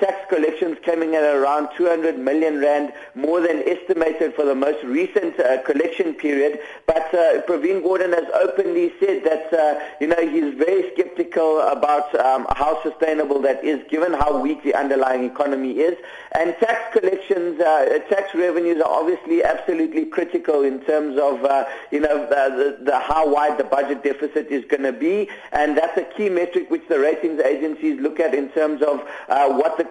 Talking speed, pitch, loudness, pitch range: 180 wpm, 155 Hz, -20 LUFS, 145-205 Hz